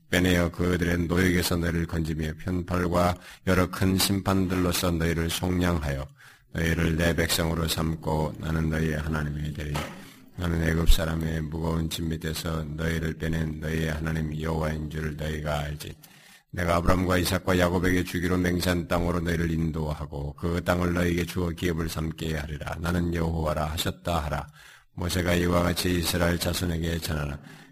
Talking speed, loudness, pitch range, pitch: 355 characters per minute, -27 LUFS, 80-90 Hz, 85 Hz